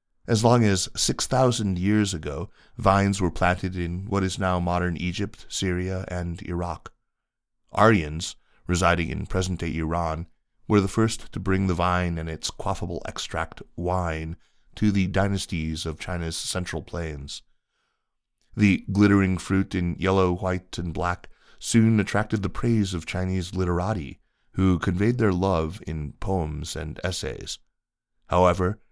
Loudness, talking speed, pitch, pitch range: -25 LUFS, 140 wpm, 90 Hz, 85-100 Hz